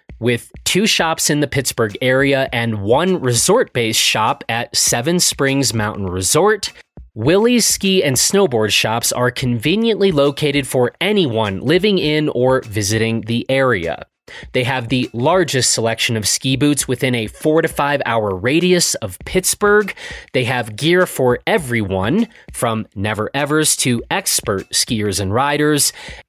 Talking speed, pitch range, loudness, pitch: 145 wpm, 115-165 Hz, -16 LUFS, 130 Hz